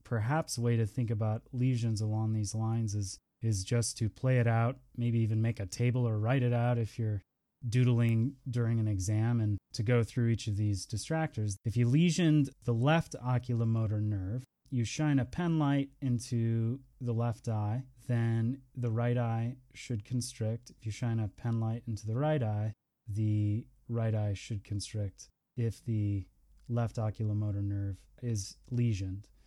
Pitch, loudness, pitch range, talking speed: 115 Hz, -33 LUFS, 110-125 Hz, 170 wpm